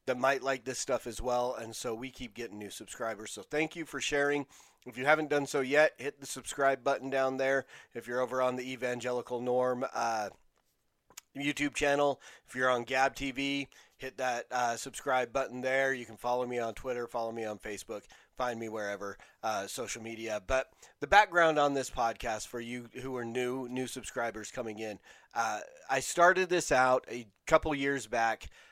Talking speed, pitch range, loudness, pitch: 190 wpm, 120-135 Hz, -32 LUFS, 130 Hz